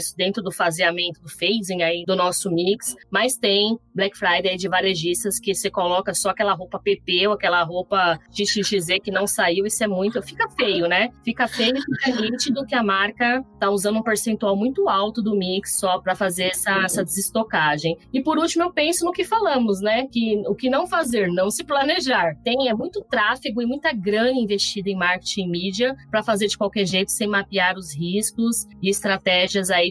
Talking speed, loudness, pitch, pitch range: 200 wpm, -21 LUFS, 200 Hz, 185-230 Hz